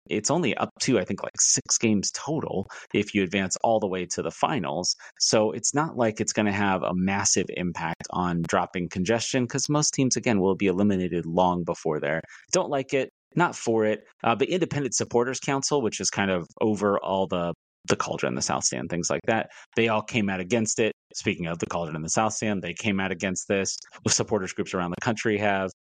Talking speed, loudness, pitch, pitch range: 220 wpm, -25 LUFS, 100 Hz, 90-115 Hz